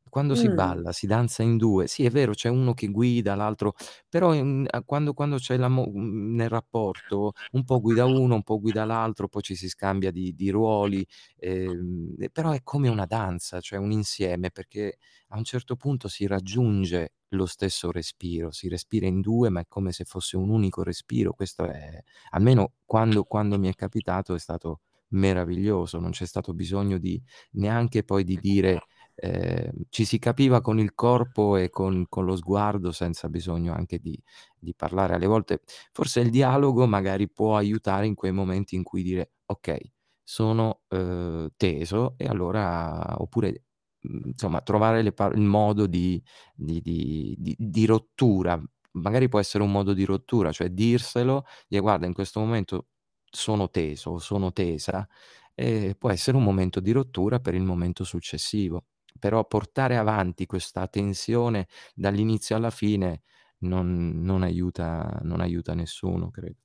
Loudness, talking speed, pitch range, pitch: -26 LUFS, 165 wpm, 90-110 Hz, 100 Hz